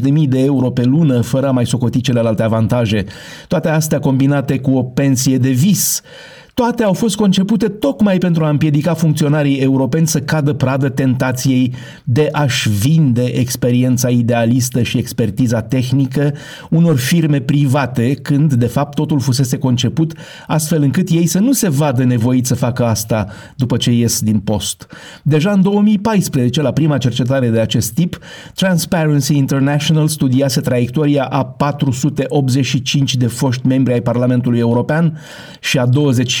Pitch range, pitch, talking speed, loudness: 125-155 Hz, 135 Hz, 150 wpm, -14 LUFS